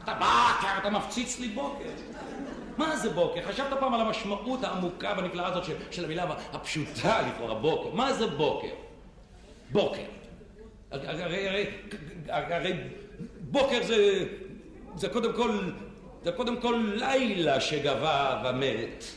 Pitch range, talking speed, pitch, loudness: 180-250 Hz, 130 wpm, 205 Hz, -29 LUFS